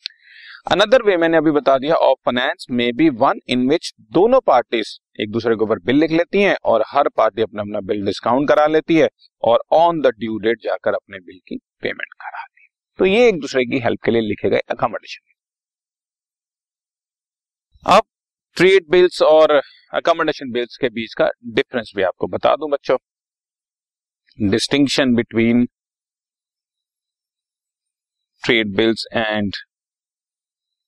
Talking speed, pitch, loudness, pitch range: 150 wpm, 135 Hz, -17 LUFS, 115-165 Hz